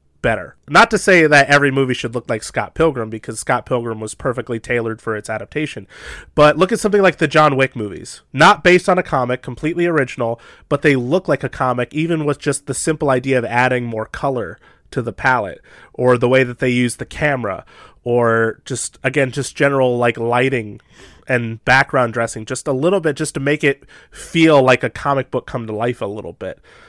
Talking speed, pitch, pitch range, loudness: 210 wpm, 130 Hz, 120-150 Hz, -16 LUFS